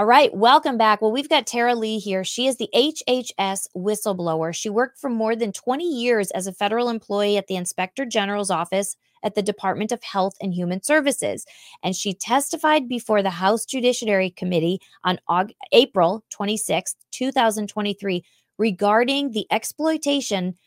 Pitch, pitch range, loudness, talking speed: 210 Hz, 190-245 Hz, -22 LUFS, 160 wpm